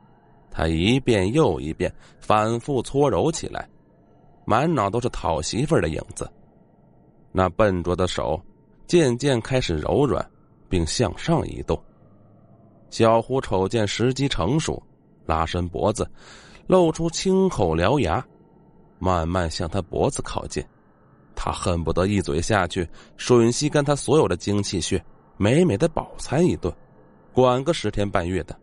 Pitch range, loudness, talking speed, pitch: 90-125 Hz, -23 LUFS, 205 characters per minute, 105 Hz